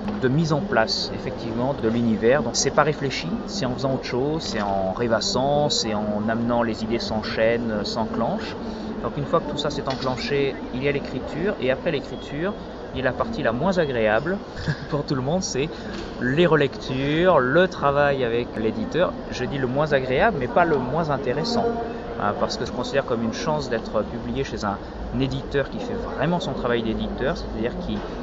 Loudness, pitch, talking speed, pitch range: -24 LUFS, 130 Hz, 195 wpm, 110-150 Hz